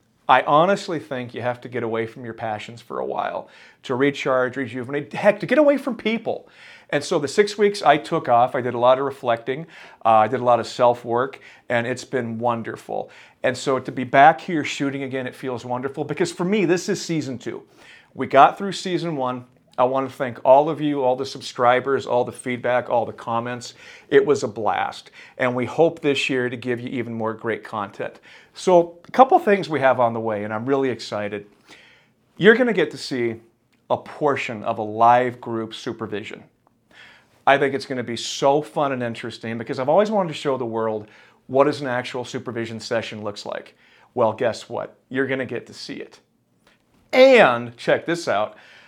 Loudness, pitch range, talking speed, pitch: -21 LUFS, 120-150 Hz, 210 wpm, 130 Hz